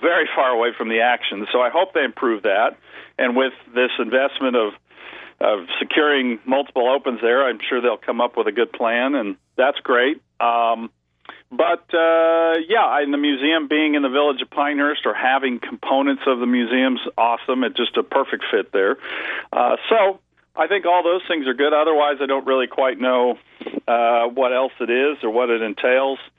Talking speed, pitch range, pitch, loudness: 195 wpm, 125-150 Hz, 135 Hz, -19 LUFS